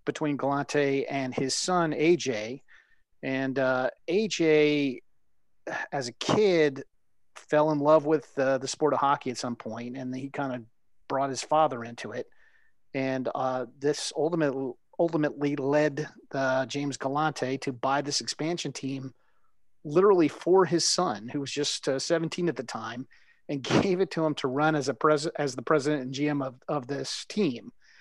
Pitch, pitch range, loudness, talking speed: 145 Hz, 135-155 Hz, -27 LUFS, 165 wpm